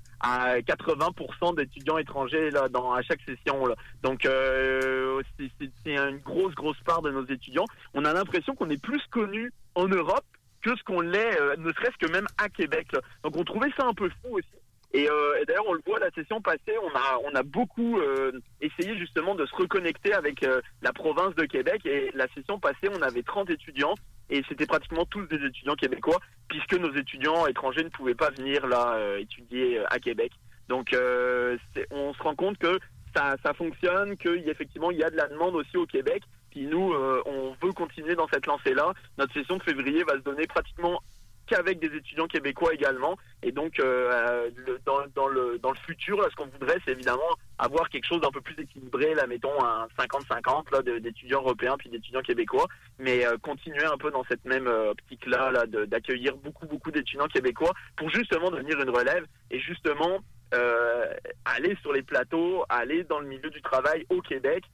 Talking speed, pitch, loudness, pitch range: 200 wpm, 155 Hz, -28 LUFS, 130-200 Hz